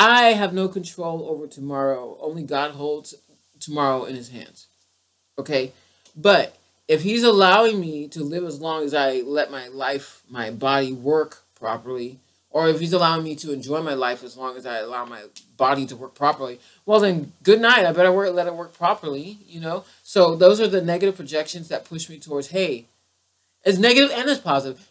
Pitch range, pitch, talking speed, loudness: 130-175 Hz, 150 Hz, 195 wpm, -21 LUFS